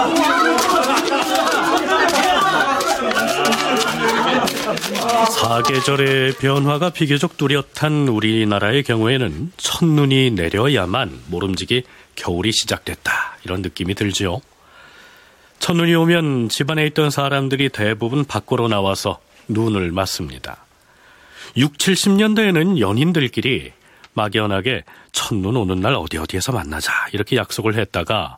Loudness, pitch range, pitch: -18 LUFS, 100-145 Hz, 125 Hz